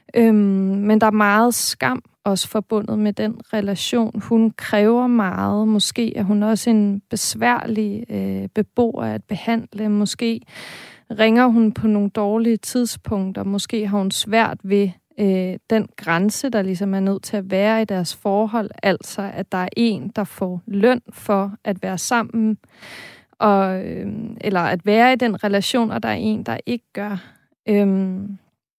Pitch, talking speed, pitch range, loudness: 210 Hz, 160 wpm, 200-225 Hz, -19 LUFS